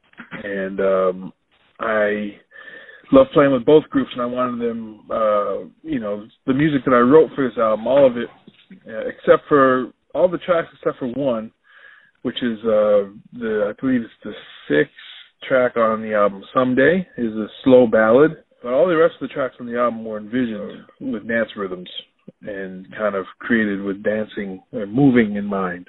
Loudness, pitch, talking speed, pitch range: -19 LUFS, 120 Hz, 180 wpm, 105-150 Hz